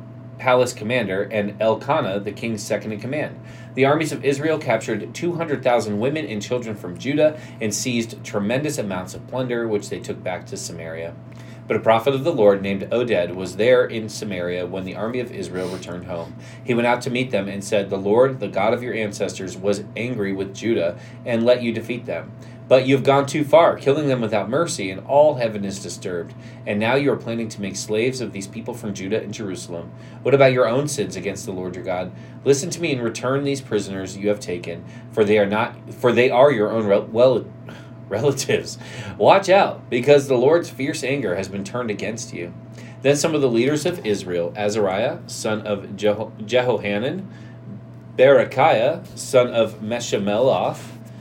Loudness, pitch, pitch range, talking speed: -21 LUFS, 115 Hz, 100-130 Hz, 195 wpm